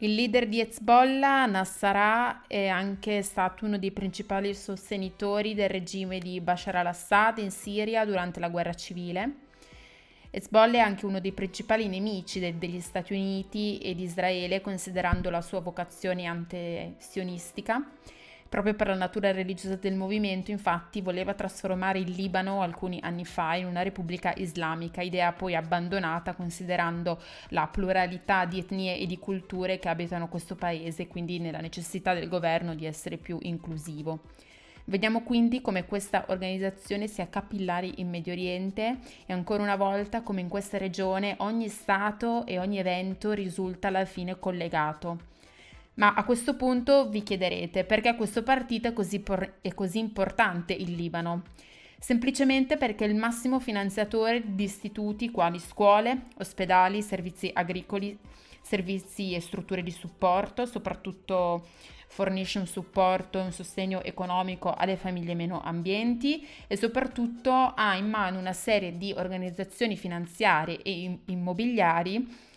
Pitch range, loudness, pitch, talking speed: 180-210 Hz, -29 LUFS, 190 Hz, 140 wpm